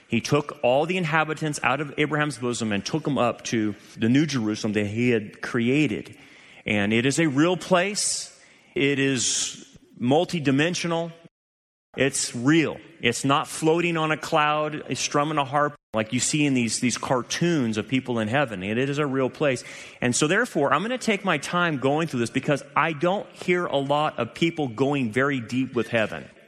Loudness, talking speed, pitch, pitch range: -24 LUFS, 190 wpm, 140 Hz, 120-155 Hz